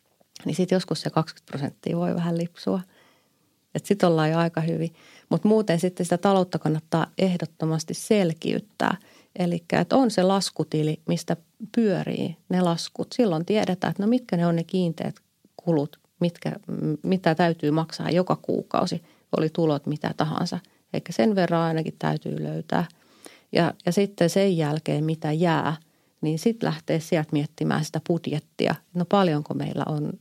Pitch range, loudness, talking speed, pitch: 155-185 Hz, -25 LUFS, 155 wpm, 170 Hz